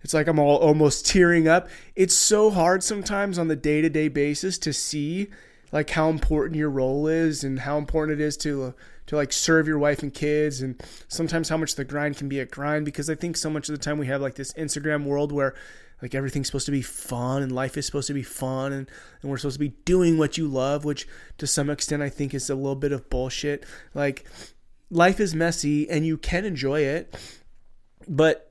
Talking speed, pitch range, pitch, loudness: 225 wpm, 140-160 Hz, 150 Hz, -24 LUFS